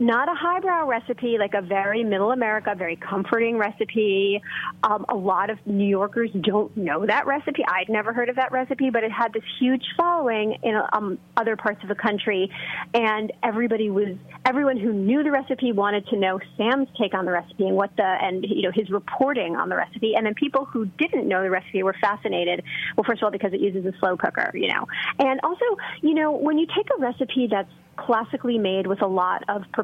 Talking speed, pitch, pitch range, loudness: 215 wpm, 220 Hz, 200-250 Hz, -23 LUFS